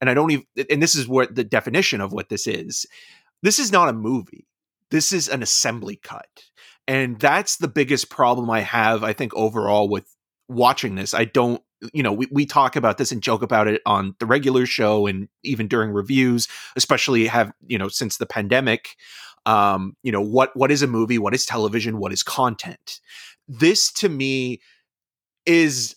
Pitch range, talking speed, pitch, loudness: 110-135 Hz, 190 wpm, 120 Hz, -20 LUFS